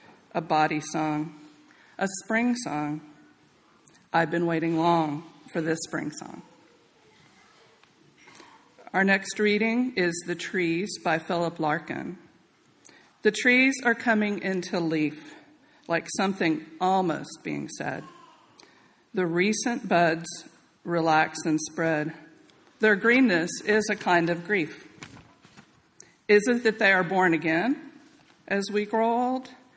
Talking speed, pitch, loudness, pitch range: 115 wpm, 180 Hz, -25 LUFS, 165-215 Hz